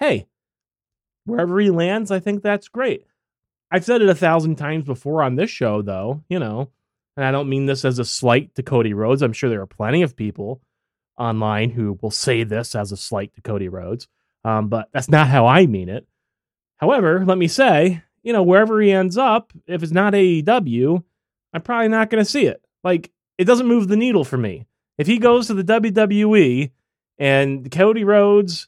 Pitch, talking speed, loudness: 155 Hz, 200 wpm, -18 LUFS